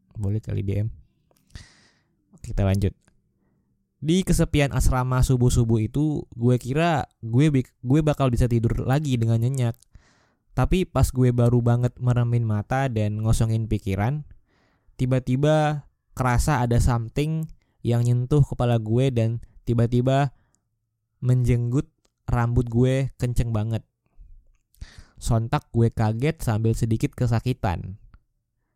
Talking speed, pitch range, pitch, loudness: 105 wpm, 115-130 Hz, 120 Hz, -23 LUFS